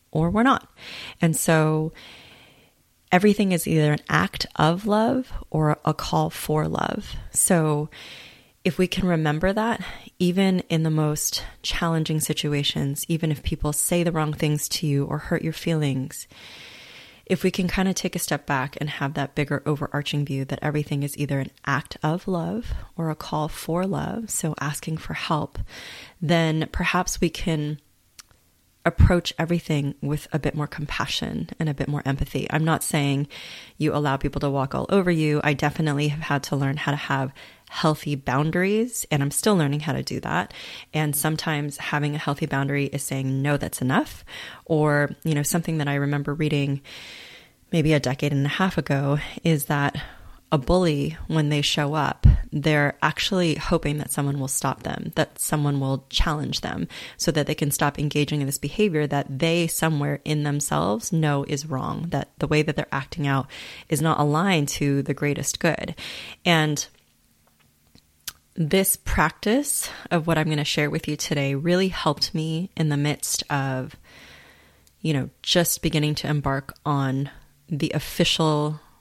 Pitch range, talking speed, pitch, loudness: 145-165 Hz, 170 wpm, 150 Hz, -24 LUFS